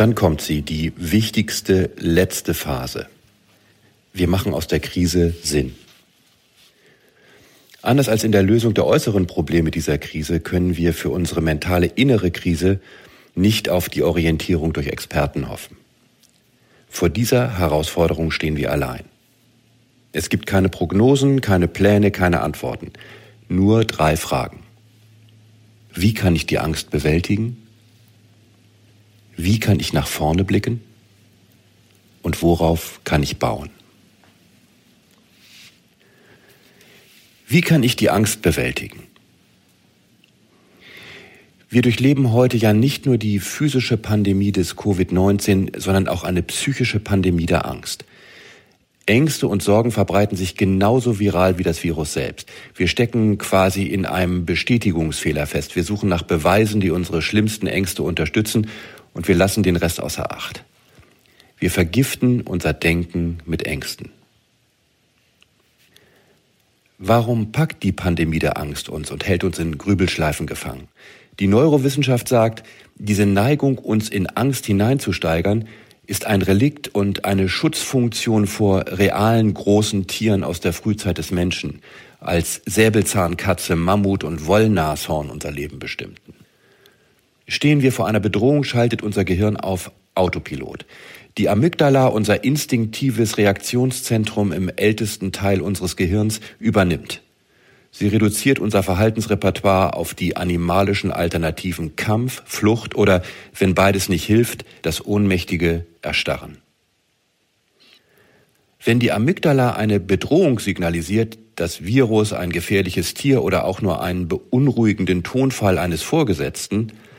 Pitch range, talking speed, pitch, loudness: 85-110 Hz, 120 wpm, 100 Hz, -19 LUFS